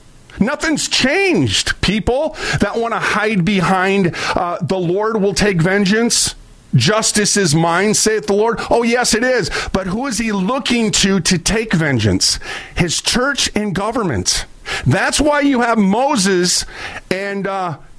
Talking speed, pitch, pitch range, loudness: 145 wpm, 205 Hz, 190-230 Hz, -15 LUFS